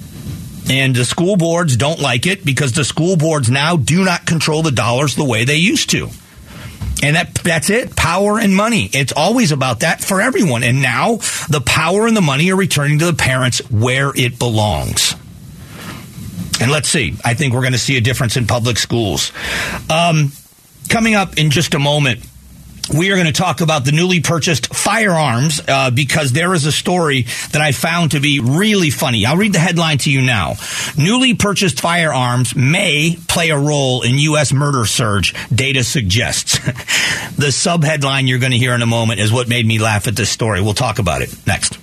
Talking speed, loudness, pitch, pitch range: 195 wpm, -14 LUFS, 145 Hz, 125-170 Hz